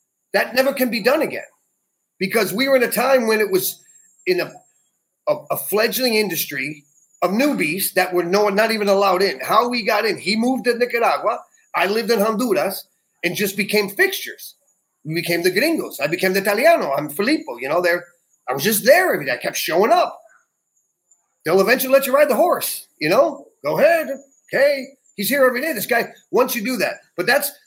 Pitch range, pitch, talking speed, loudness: 190-275 Hz, 225 Hz, 205 wpm, -19 LUFS